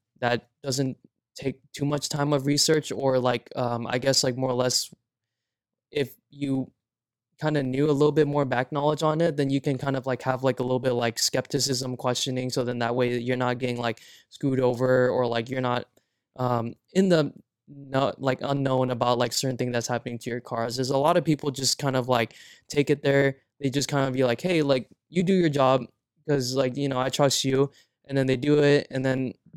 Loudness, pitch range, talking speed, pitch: -25 LUFS, 125-140 Hz, 225 wpm, 130 Hz